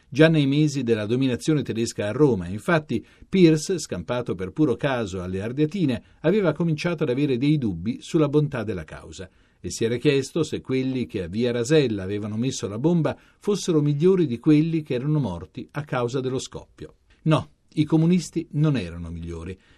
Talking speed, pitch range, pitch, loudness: 175 wpm, 115-155 Hz, 135 Hz, -23 LUFS